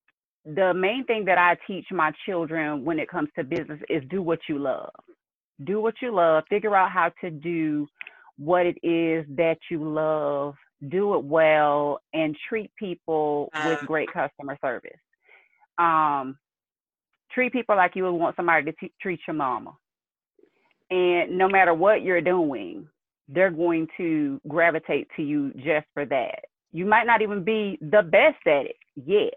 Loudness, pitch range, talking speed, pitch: -24 LUFS, 155-220 Hz, 165 wpm, 175 Hz